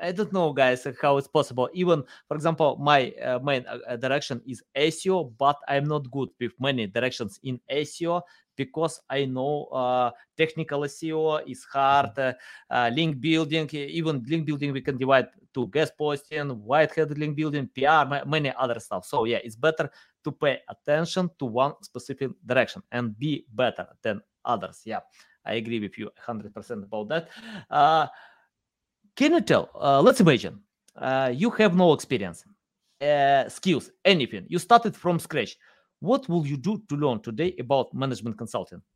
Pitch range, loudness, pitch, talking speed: 130-160 Hz, -25 LUFS, 145 Hz, 170 wpm